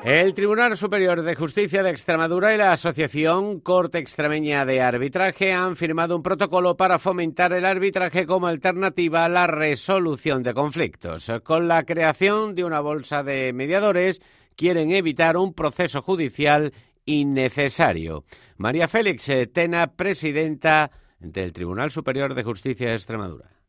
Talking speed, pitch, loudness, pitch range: 135 wpm, 165 Hz, -21 LUFS, 140-185 Hz